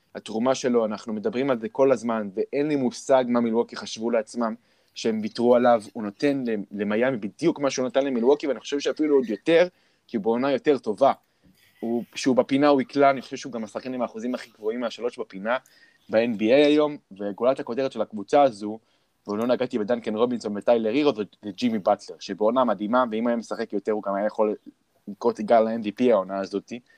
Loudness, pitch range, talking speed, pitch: -24 LUFS, 110-135 Hz, 195 wpm, 120 Hz